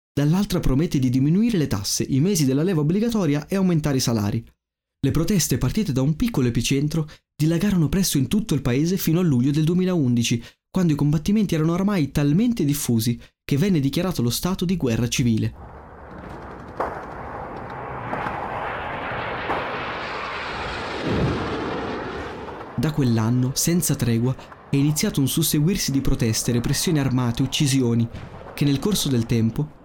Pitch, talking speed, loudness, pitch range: 145 Hz, 135 wpm, -22 LUFS, 125-170 Hz